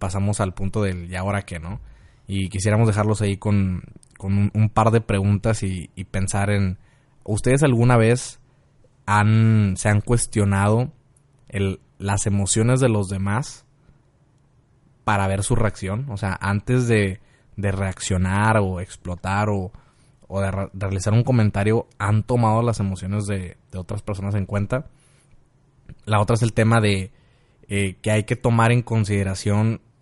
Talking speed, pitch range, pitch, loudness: 155 wpm, 100-120 Hz, 105 Hz, -21 LUFS